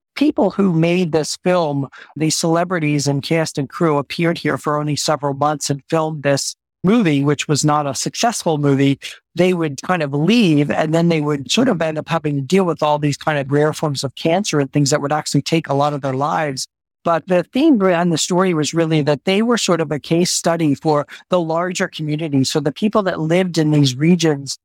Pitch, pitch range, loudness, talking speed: 155 Hz, 145-175 Hz, -17 LUFS, 220 wpm